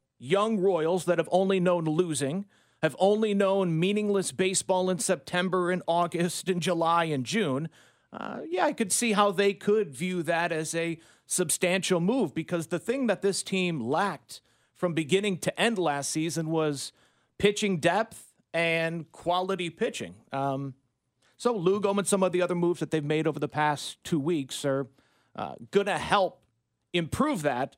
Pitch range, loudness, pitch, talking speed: 160-195 Hz, -27 LUFS, 180 Hz, 165 wpm